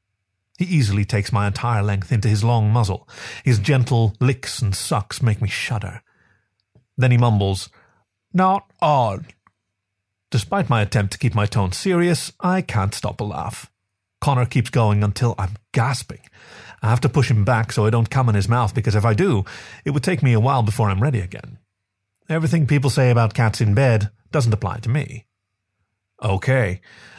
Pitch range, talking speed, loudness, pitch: 100-130 Hz, 180 wpm, -20 LUFS, 110 Hz